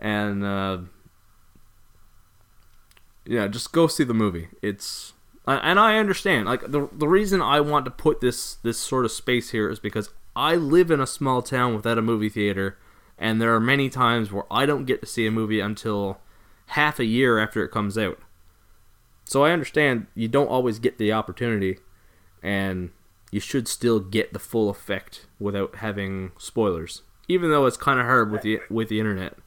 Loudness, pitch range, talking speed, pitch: -23 LUFS, 100-125 Hz, 185 wpm, 110 Hz